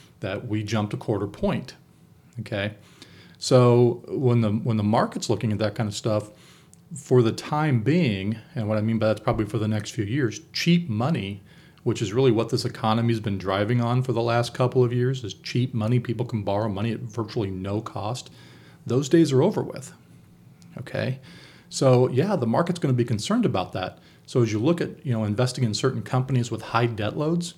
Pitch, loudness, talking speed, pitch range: 120 Hz, -24 LUFS, 200 wpm, 110-130 Hz